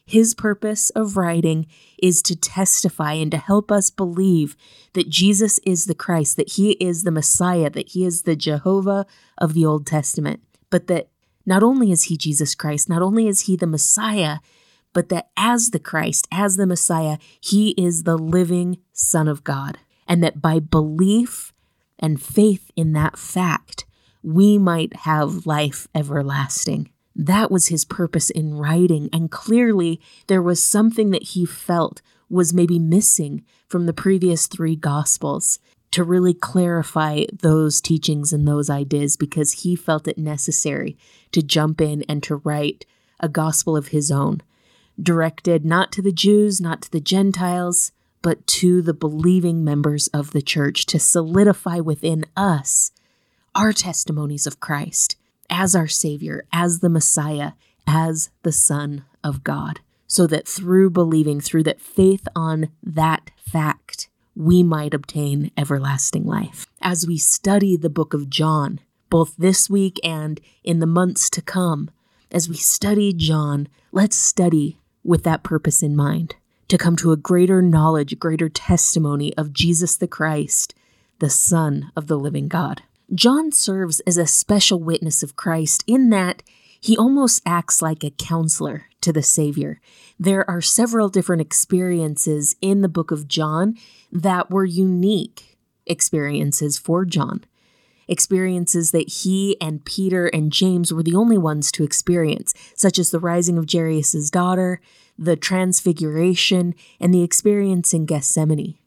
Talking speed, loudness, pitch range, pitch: 155 wpm, -18 LUFS, 155-185 Hz, 170 Hz